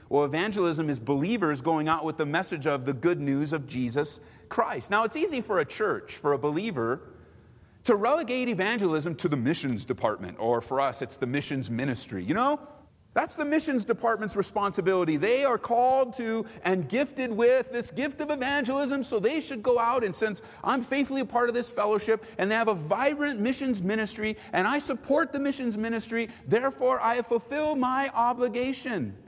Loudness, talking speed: -27 LUFS, 180 wpm